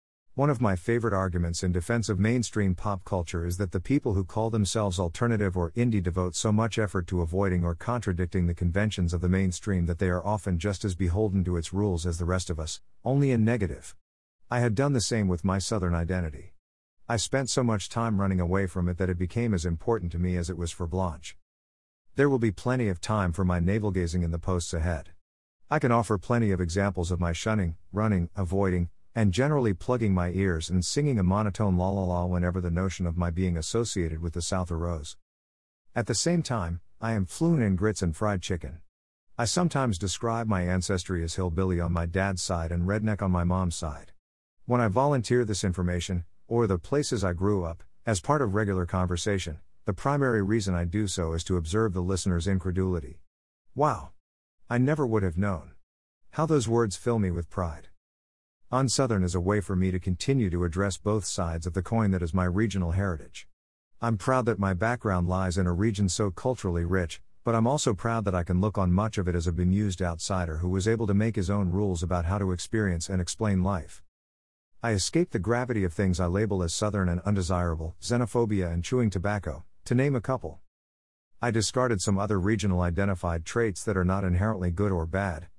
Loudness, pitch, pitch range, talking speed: -28 LUFS, 95 Hz, 90-110 Hz, 210 wpm